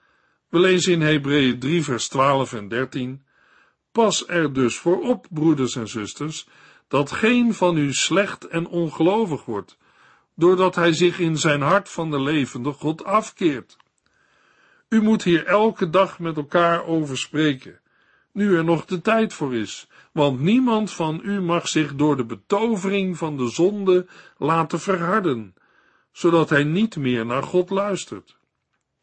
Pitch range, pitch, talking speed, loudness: 145-190 Hz, 165 Hz, 150 wpm, -21 LUFS